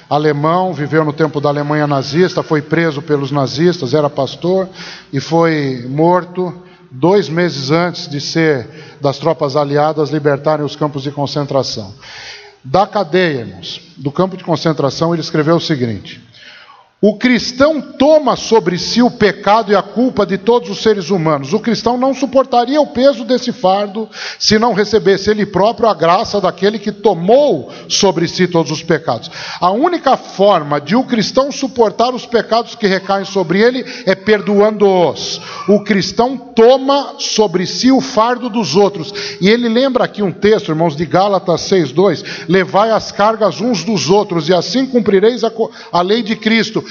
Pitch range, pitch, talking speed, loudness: 160-225 Hz, 190 Hz, 160 wpm, -14 LUFS